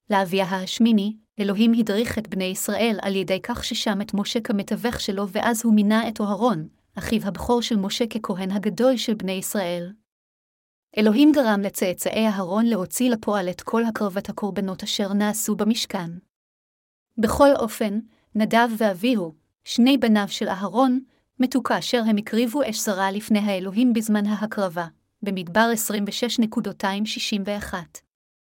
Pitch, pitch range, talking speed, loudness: 215 Hz, 200-230 Hz, 130 wpm, -23 LUFS